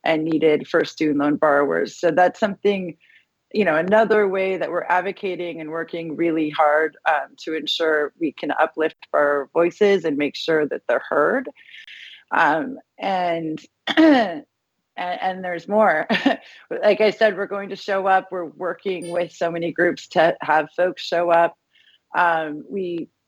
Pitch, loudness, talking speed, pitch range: 175 Hz, -21 LUFS, 155 wpm, 160-195 Hz